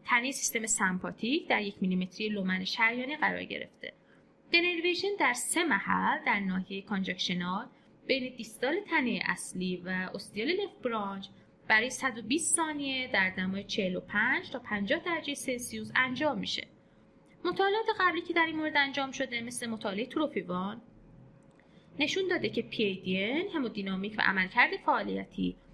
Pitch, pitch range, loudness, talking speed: 235 Hz, 195-305 Hz, -30 LUFS, 130 wpm